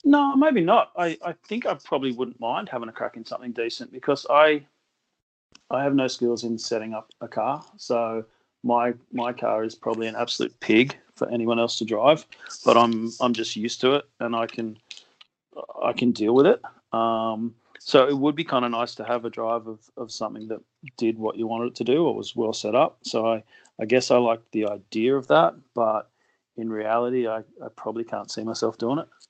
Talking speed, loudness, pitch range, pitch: 215 wpm, -24 LUFS, 115-125 Hz, 115 Hz